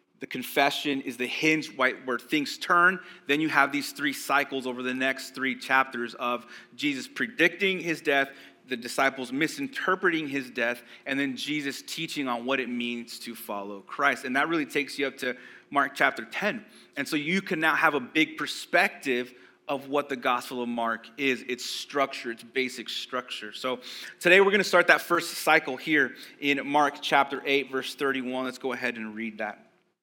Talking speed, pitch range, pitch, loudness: 185 wpm, 125-155 Hz, 135 Hz, -27 LUFS